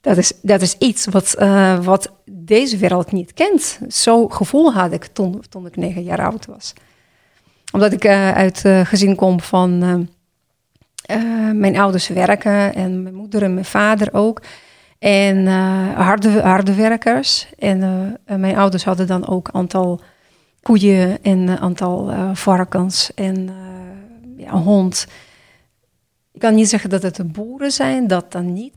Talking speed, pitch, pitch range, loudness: 165 wpm, 195 Hz, 185-215 Hz, -15 LUFS